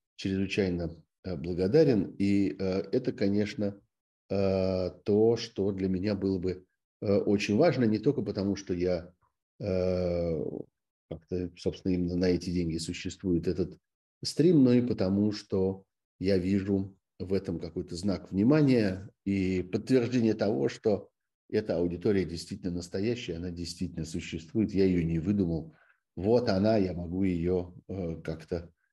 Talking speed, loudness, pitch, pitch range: 135 wpm, -29 LUFS, 95 Hz, 90-100 Hz